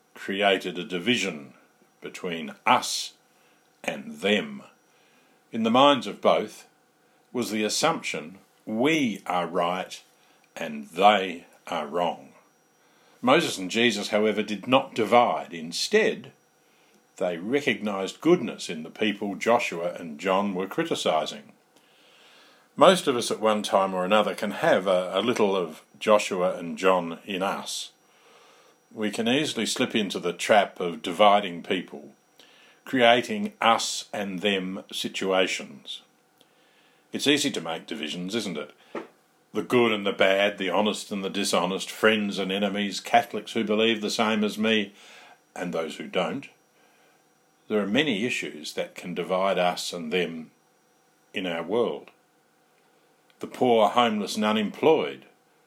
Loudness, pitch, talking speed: -25 LUFS, 110 Hz, 135 wpm